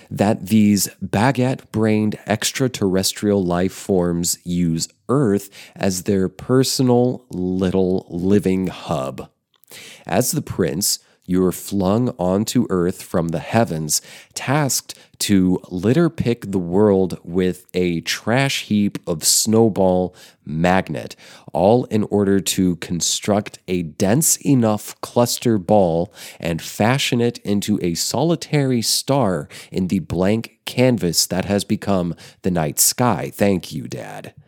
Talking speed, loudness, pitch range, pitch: 120 wpm, -19 LUFS, 90-115 Hz, 100 Hz